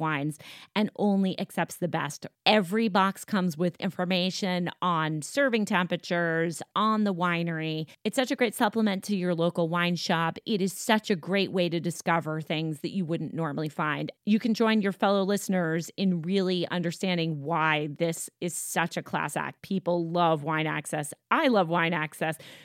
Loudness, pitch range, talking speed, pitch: -28 LUFS, 160-195 Hz, 170 wpm, 175 Hz